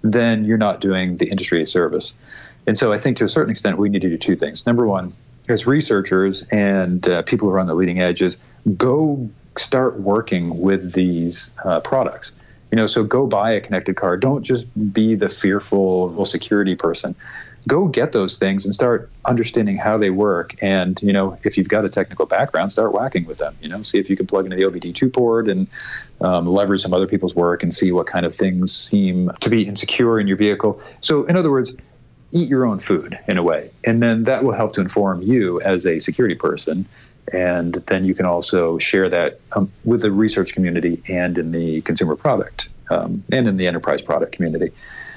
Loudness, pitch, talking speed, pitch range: -18 LUFS, 100 Hz, 210 wpm, 90-115 Hz